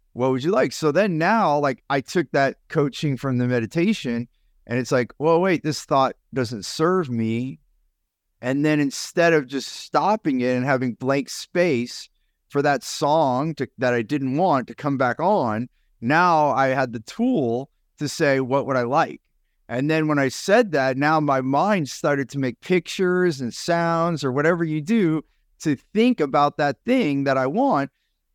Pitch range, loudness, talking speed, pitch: 130-160 Hz, -22 LUFS, 180 wpm, 140 Hz